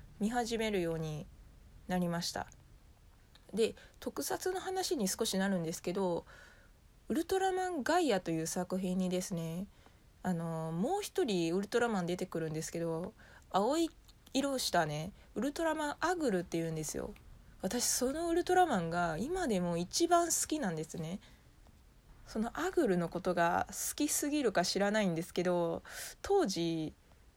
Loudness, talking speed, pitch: -35 LUFS, 300 characters per minute, 190 Hz